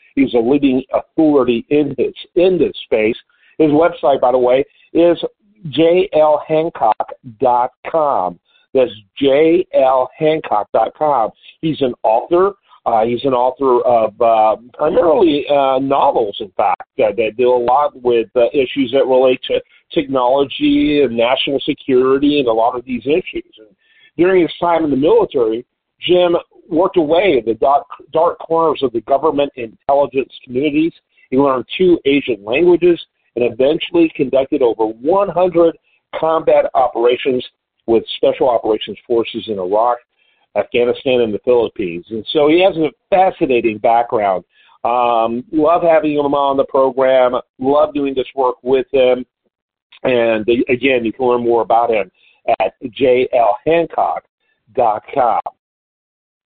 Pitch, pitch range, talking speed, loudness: 140 Hz, 125-170 Hz, 135 wpm, -15 LUFS